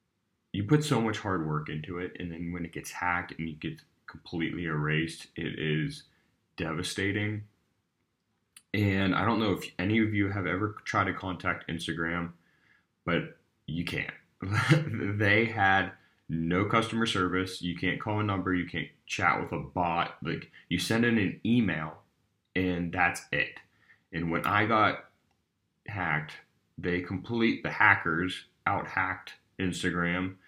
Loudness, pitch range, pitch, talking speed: -30 LUFS, 85-105 Hz, 95 Hz, 150 wpm